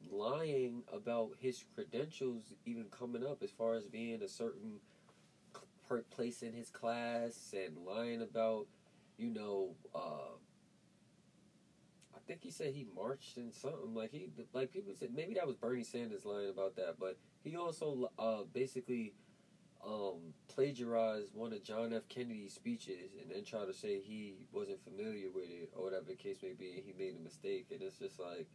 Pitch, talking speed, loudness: 130 Hz, 175 wpm, -44 LUFS